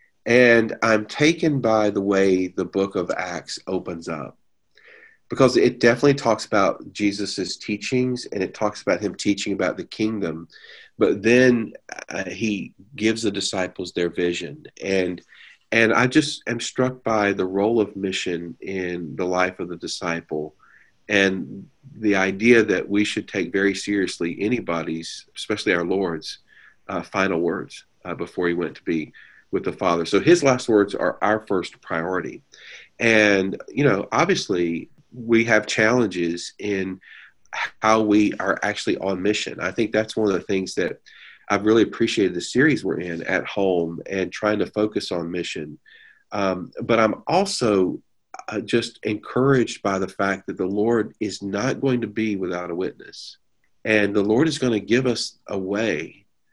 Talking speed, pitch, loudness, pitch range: 165 wpm, 105 Hz, -22 LUFS, 95-115 Hz